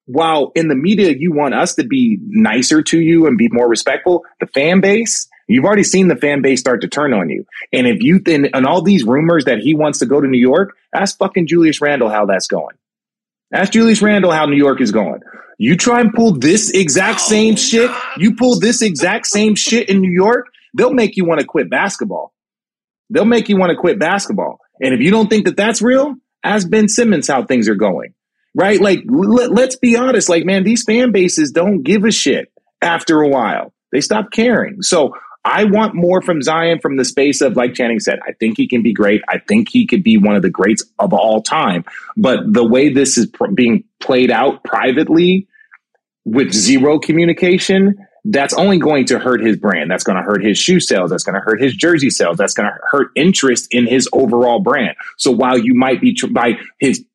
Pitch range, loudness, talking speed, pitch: 150-220 Hz, -13 LUFS, 220 wpm, 190 Hz